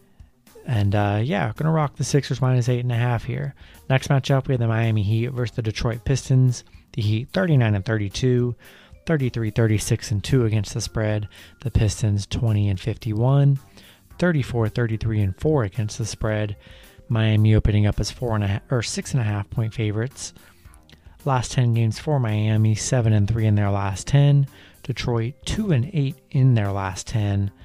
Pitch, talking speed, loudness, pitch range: 115 Hz, 180 wpm, -22 LUFS, 105-130 Hz